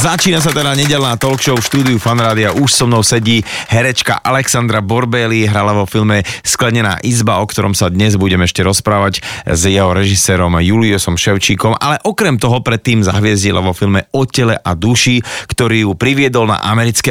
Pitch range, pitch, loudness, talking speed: 100-125 Hz, 115 Hz, -12 LUFS, 170 wpm